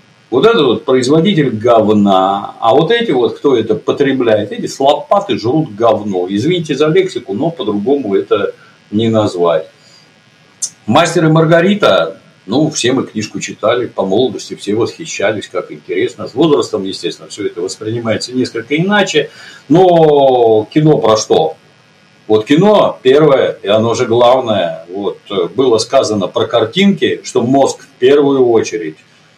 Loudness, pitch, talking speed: -12 LUFS, 160 Hz, 135 wpm